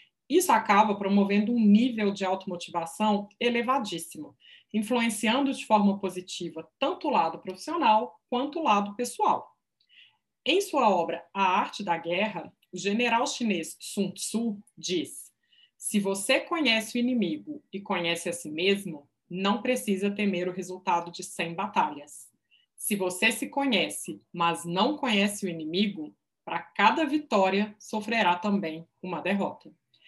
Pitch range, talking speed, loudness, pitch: 180-235 Hz, 135 wpm, -27 LUFS, 200 Hz